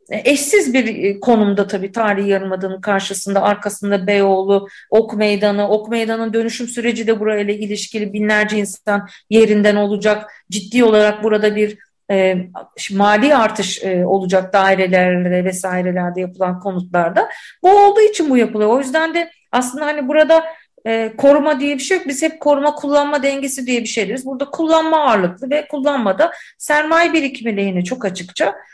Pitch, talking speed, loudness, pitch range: 215 Hz, 150 wpm, -16 LUFS, 200-280 Hz